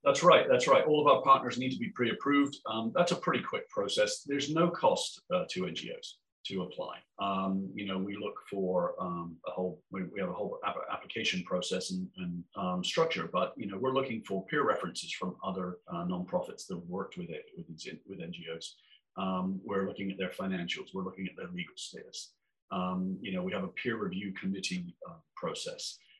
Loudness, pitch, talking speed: -33 LUFS, 100 Hz, 200 wpm